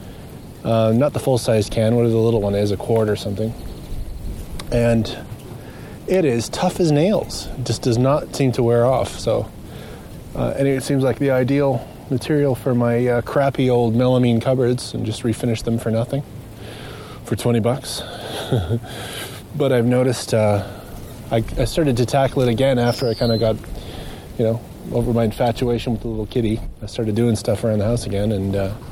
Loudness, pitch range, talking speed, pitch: -20 LUFS, 110-130 Hz, 185 wpm, 120 Hz